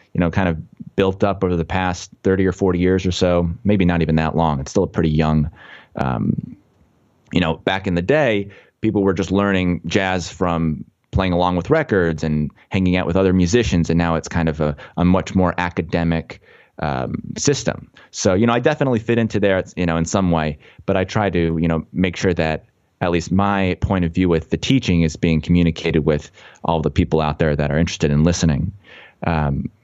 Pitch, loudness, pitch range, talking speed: 90 Hz, -19 LUFS, 80-95 Hz, 215 wpm